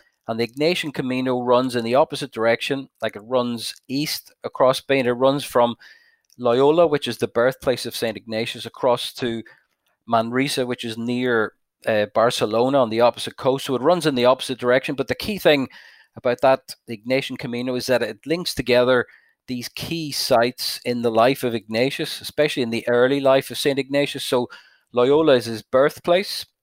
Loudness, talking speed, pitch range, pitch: -21 LUFS, 180 wpm, 120-140 Hz, 125 Hz